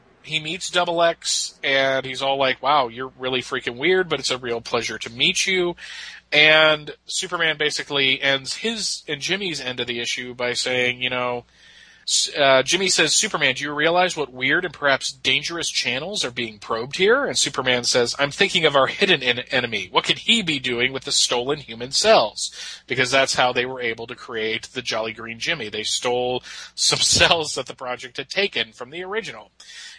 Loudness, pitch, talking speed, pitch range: -20 LUFS, 135 Hz, 195 wpm, 125-160 Hz